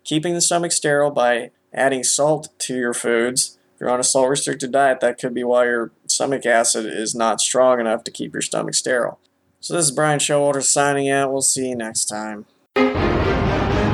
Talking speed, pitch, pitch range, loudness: 195 wpm, 130 Hz, 120-145 Hz, -19 LUFS